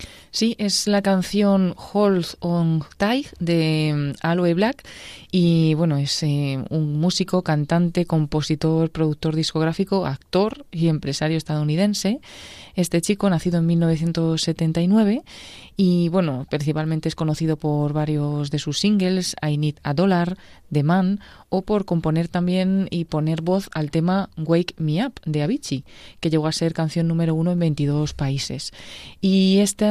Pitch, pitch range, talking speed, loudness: 165 Hz, 155-190 Hz, 140 wpm, -21 LUFS